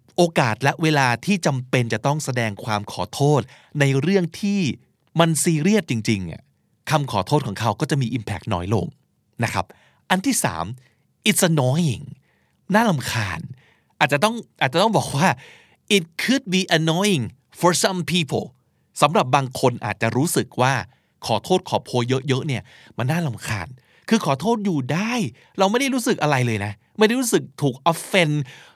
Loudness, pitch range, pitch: -21 LUFS, 125-185 Hz, 150 Hz